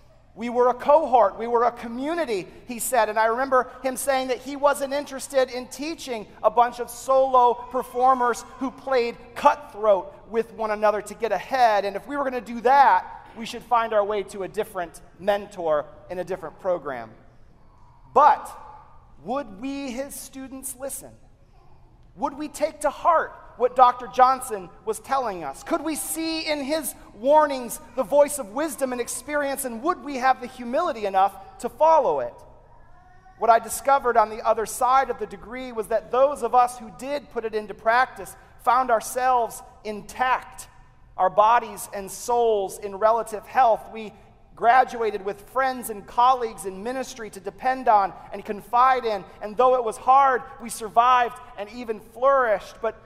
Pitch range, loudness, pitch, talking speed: 215-265 Hz, -23 LUFS, 245 Hz, 170 wpm